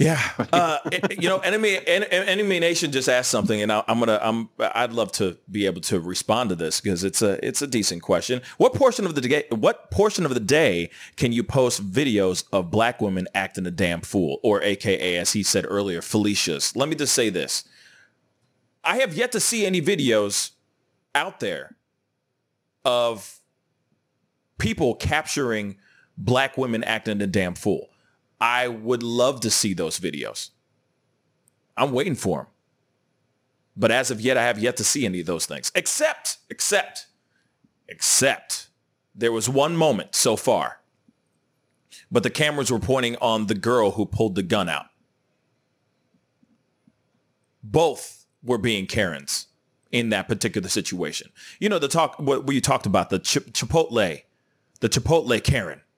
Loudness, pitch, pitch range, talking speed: -22 LUFS, 115 Hz, 105-135 Hz, 160 wpm